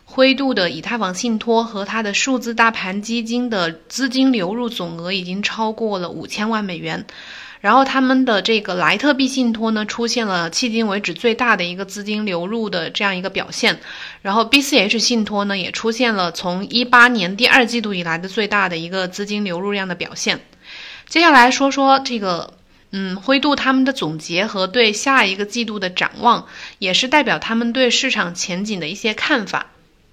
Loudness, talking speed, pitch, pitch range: -17 LUFS, 295 characters per minute, 220 Hz, 190-245 Hz